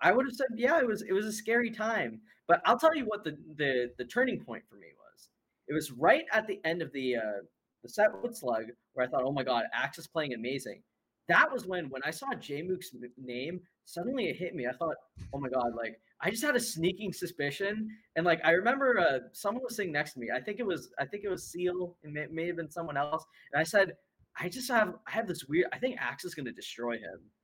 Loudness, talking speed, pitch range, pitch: -32 LUFS, 260 wpm, 140-215 Hz, 170 Hz